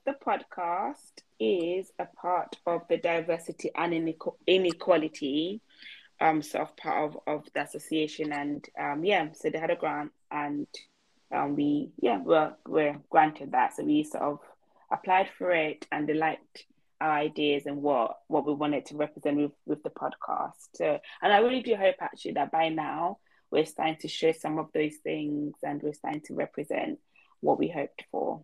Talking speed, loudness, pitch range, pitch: 180 wpm, -29 LUFS, 150-175 Hz, 160 Hz